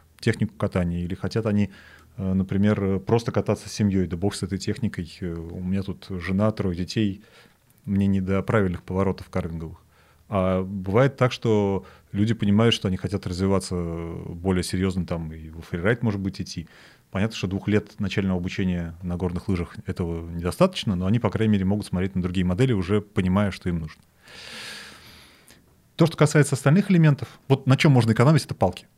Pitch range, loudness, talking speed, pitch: 90-110 Hz, -24 LUFS, 175 wpm, 95 Hz